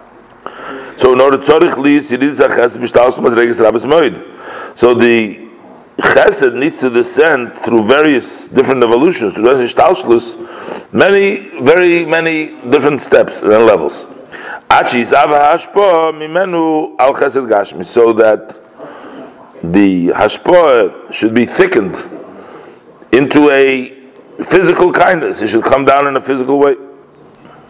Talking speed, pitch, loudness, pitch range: 90 wpm, 145 Hz, -10 LUFS, 130-200 Hz